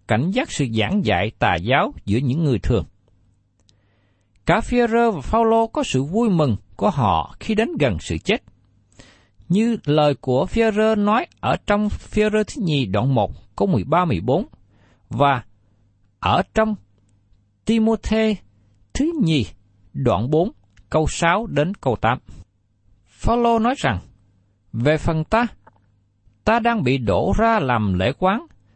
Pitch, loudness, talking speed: 125 Hz, -20 LUFS, 140 wpm